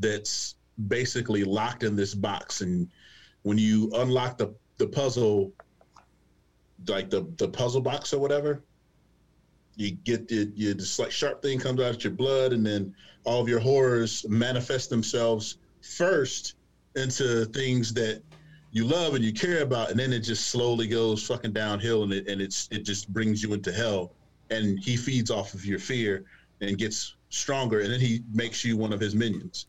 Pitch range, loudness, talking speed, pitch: 105-125 Hz, -28 LUFS, 180 wpm, 110 Hz